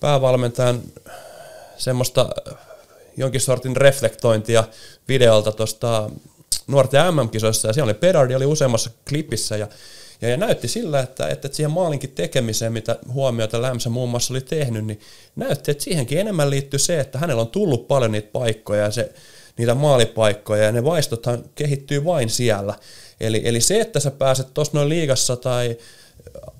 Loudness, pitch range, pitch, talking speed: -20 LUFS, 115-140 Hz, 125 Hz, 150 wpm